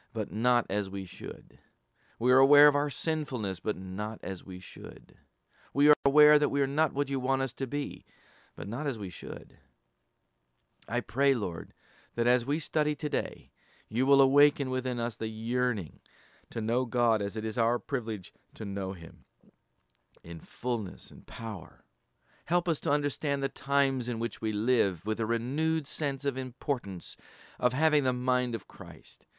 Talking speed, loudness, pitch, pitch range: 175 wpm, -29 LUFS, 125 Hz, 110-140 Hz